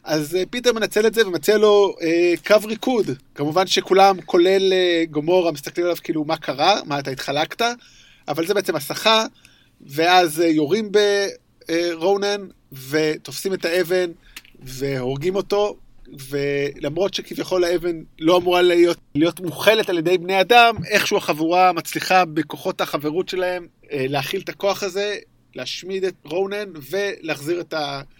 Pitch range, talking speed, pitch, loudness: 155-195 Hz, 130 wpm, 175 Hz, -20 LUFS